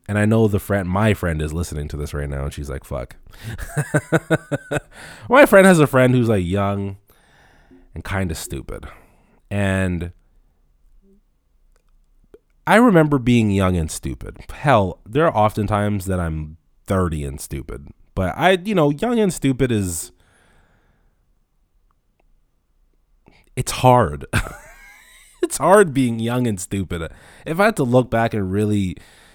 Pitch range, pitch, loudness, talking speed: 85-130 Hz, 100 Hz, -19 LUFS, 145 wpm